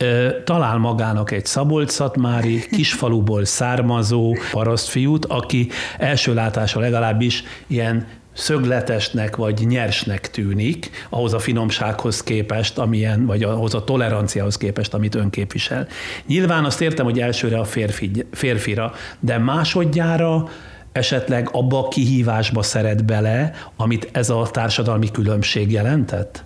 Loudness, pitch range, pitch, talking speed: -19 LUFS, 110-125 Hz, 115 Hz, 115 wpm